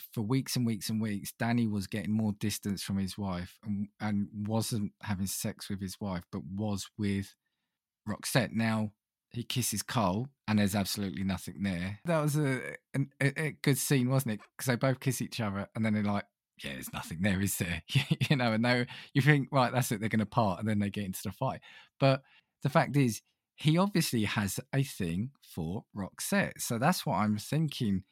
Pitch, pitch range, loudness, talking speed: 110 Hz, 100-130 Hz, -32 LUFS, 205 wpm